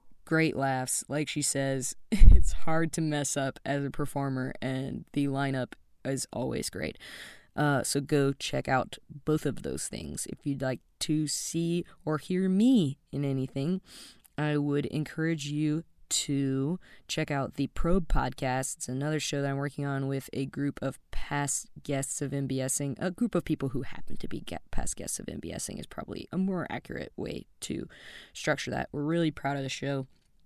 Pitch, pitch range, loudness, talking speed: 145 Hz, 135-155 Hz, -31 LUFS, 180 wpm